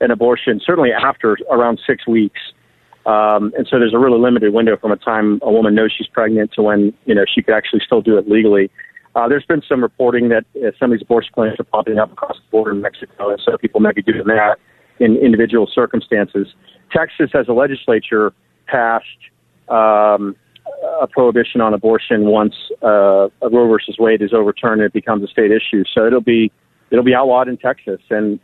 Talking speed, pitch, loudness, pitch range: 205 wpm, 110 Hz, -14 LUFS, 105-115 Hz